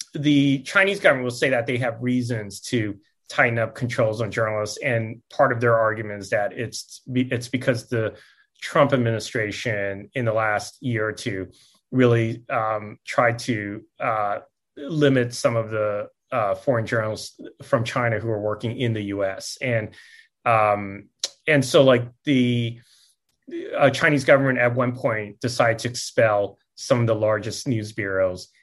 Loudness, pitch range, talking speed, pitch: -23 LUFS, 110-130 Hz, 155 wpm, 120 Hz